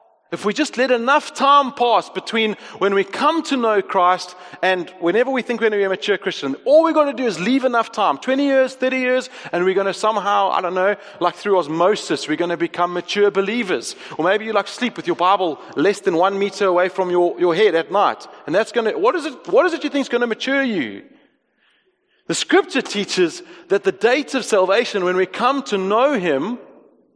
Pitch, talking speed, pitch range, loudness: 210 Hz, 230 wpm, 185-265 Hz, -18 LUFS